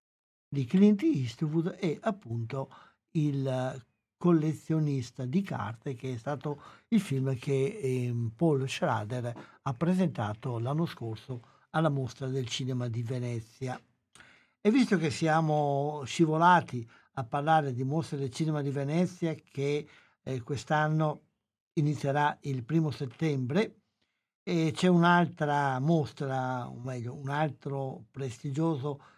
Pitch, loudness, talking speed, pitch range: 145 Hz, -30 LUFS, 115 wpm, 130-160 Hz